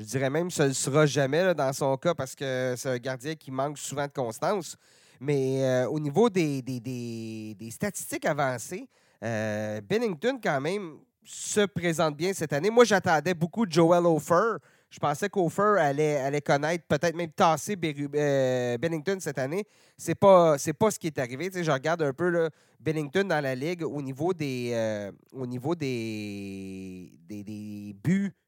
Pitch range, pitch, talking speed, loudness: 130-175 Hz, 150 Hz, 195 wpm, -27 LUFS